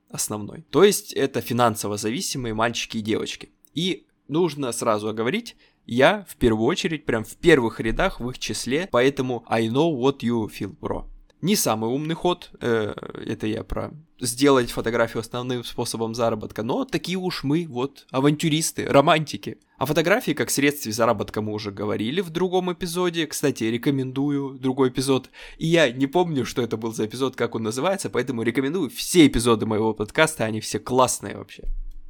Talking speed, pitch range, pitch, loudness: 165 wpm, 115-155 Hz, 125 Hz, -23 LUFS